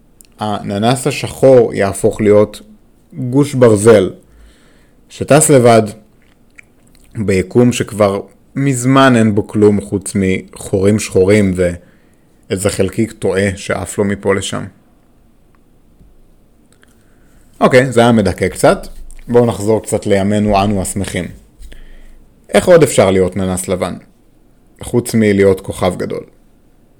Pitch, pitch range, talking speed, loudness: 105 Hz, 95-115 Hz, 100 wpm, -13 LUFS